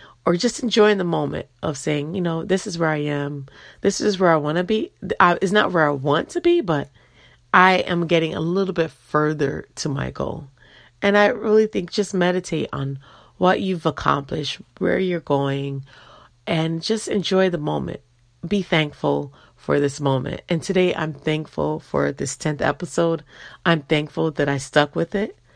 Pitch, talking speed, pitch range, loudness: 160 Hz, 180 wpm, 145-185 Hz, -21 LUFS